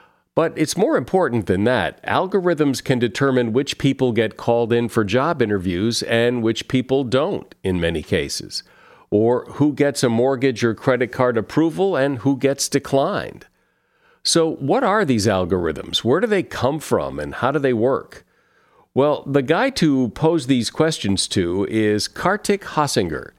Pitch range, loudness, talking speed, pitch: 115-150 Hz, -19 LUFS, 160 wpm, 130 Hz